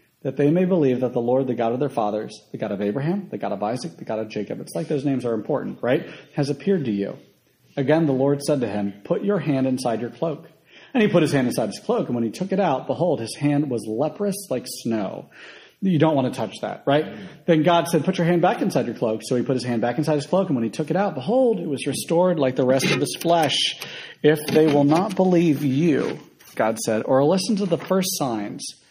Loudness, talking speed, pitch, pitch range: -22 LUFS, 255 wpm, 145 Hz, 125-170 Hz